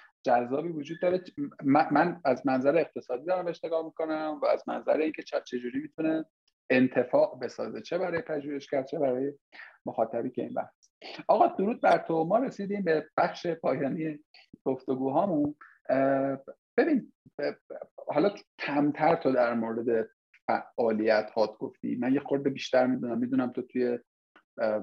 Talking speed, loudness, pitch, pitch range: 140 wpm, -29 LUFS, 140 Hz, 125-165 Hz